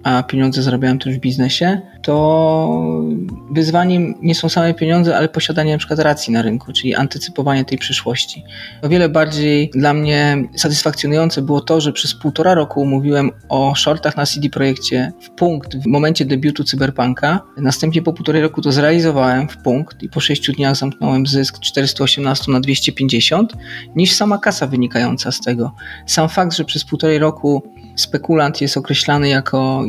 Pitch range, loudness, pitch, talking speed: 130-155 Hz, -15 LUFS, 145 Hz, 160 wpm